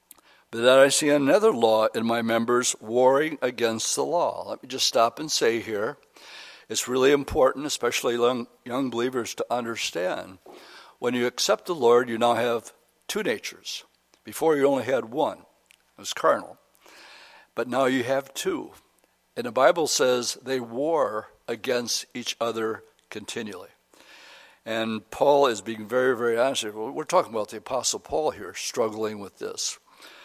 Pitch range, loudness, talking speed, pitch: 115-130 Hz, -25 LUFS, 155 wpm, 120 Hz